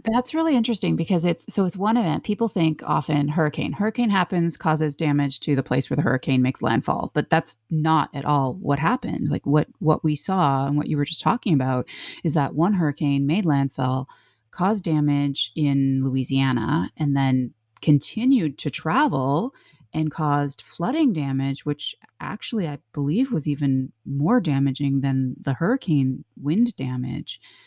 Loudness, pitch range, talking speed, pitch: -23 LUFS, 135-170 Hz, 165 wpm, 150 Hz